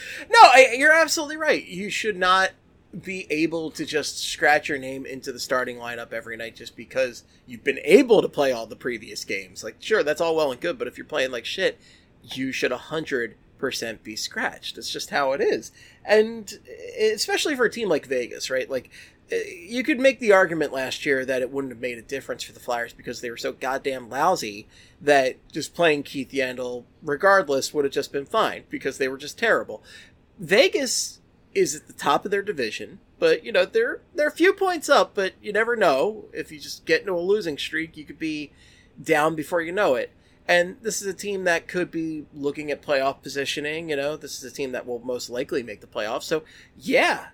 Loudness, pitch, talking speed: -23 LUFS, 160 Hz, 210 wpm